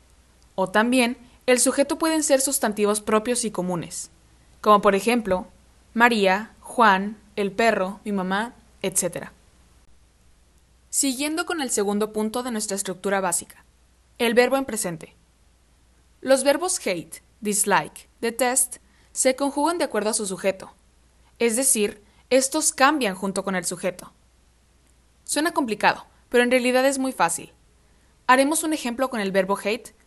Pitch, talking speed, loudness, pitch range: 210 Hz, 135 wpm, -22 LUFS, 175-250 Hz